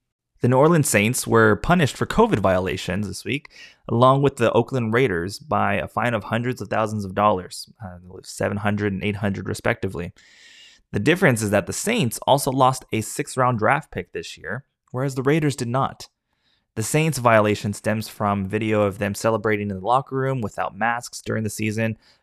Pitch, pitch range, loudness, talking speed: 110 Hz, 105-125 Hz, -21 LUFS, 180 wpm